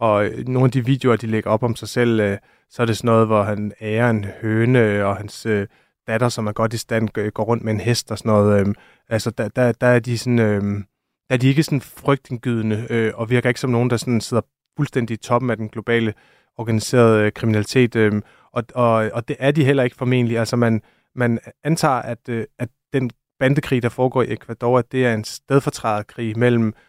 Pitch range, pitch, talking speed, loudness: 110-125 Hz, 115 Hz, 210 wpm, -20 LUFS